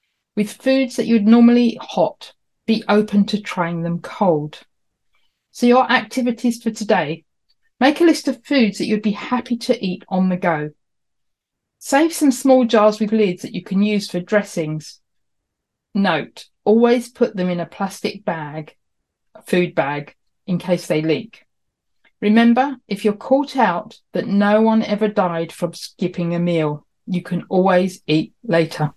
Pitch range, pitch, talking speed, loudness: 170-235 Hz, 205 Hz, 160 wpm, -18 LUFS